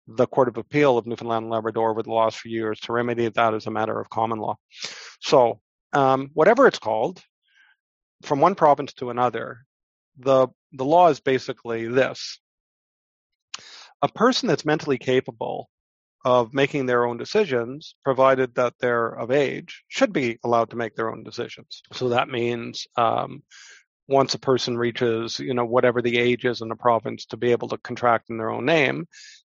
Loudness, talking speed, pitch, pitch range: -22 LUFS, 175 wpm, 125 Hz, 115-135 Hz